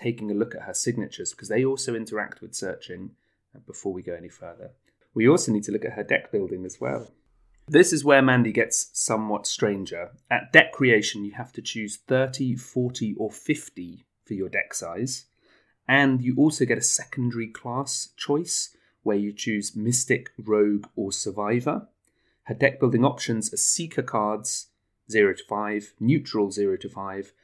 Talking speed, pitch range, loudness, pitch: 175 wpm, 105-130 Hz, -24 LUFS, 115 Hz